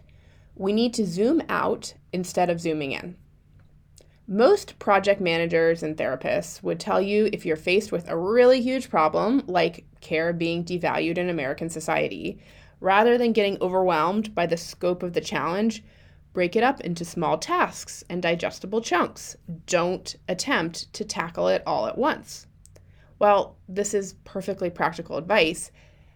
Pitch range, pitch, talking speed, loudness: 160-205 Hz, 175 Hz, 150 wpm, -24 LUFS